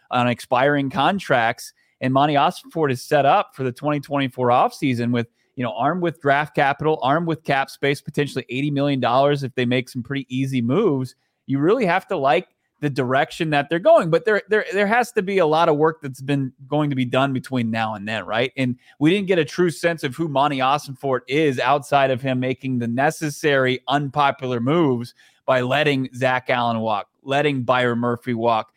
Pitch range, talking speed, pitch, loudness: 125-150 Hz, 200 wpm, 135 Hz, -20 LUFS